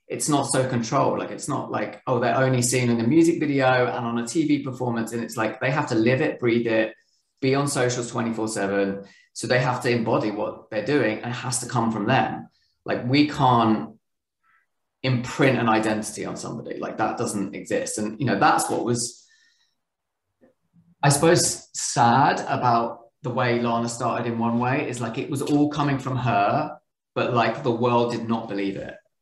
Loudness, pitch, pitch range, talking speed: -23 LUFS, 125 Hz, 115-135 Hz, 195 wpm